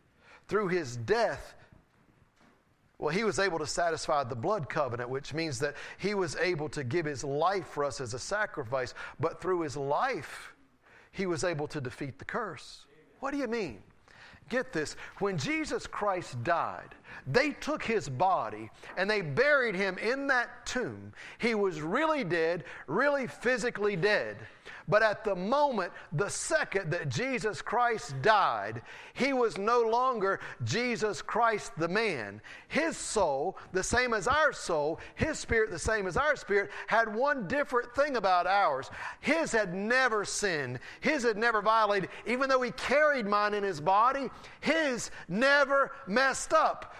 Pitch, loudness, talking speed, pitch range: 205 Hz, -30 LUFS, 160 wpm, 165-250 Hz